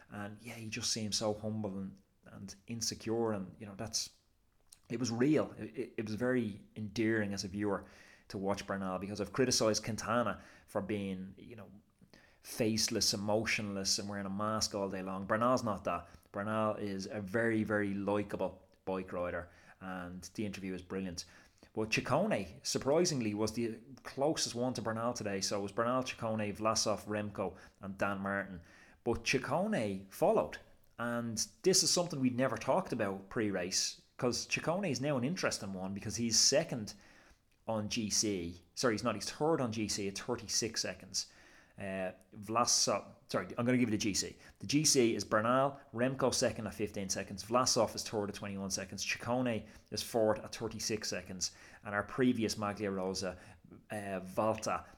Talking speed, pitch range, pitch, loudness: 165 wpm, 100-115 Hz, 105 Hz, -35 LUFS